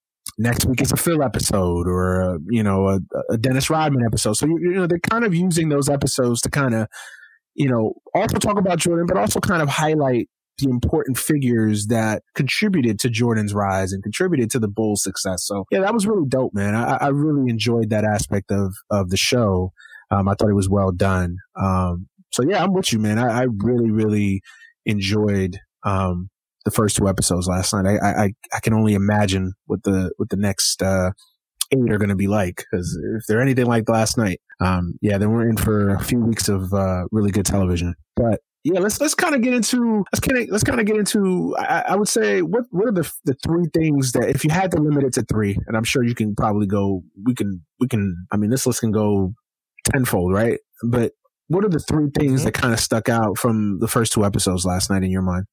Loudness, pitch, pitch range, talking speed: -20 LUFS, 110 Hz, 100-145 Hz, 230 wpm